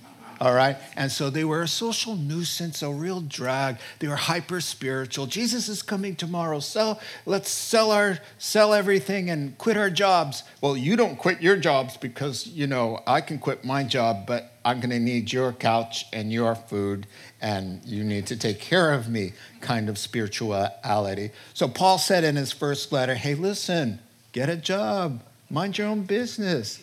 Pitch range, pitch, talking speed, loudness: 120-185 Hz, 140 Hz, 180 wpm, -25 LUFS